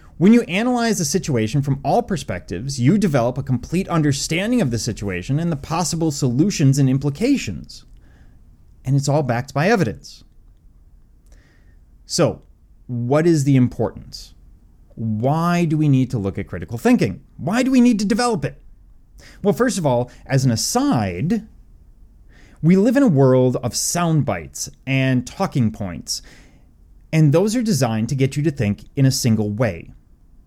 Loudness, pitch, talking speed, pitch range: -19 LUFS, 135 Hz, 160 wpm, 110-170 Hz